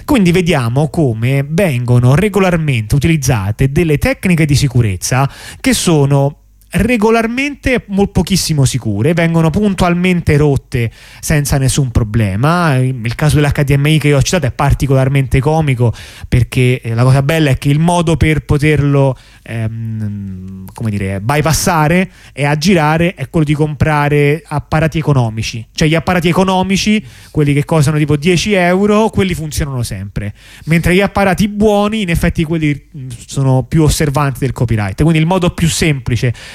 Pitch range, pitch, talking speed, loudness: 125-170 Hz, 145 Hz, 135 wpm, -13 LUFS